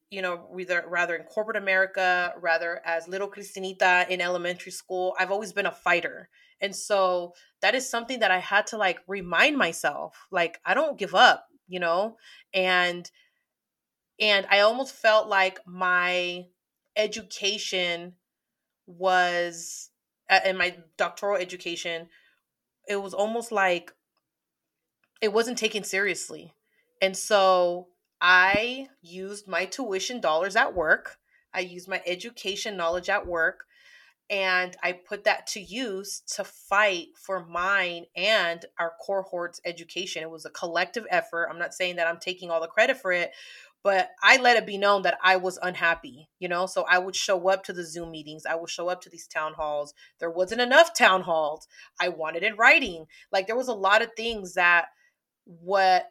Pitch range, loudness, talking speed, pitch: 175-205 Hz, -25 LUFS, 165 wpm, 185 Hz